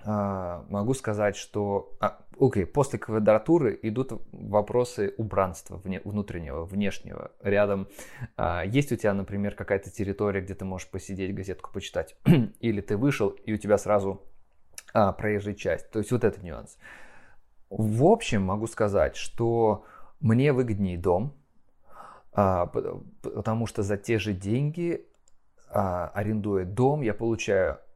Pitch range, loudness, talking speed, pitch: 95-115 Hz, -27 LUFS, 135 wpm, 105 Hz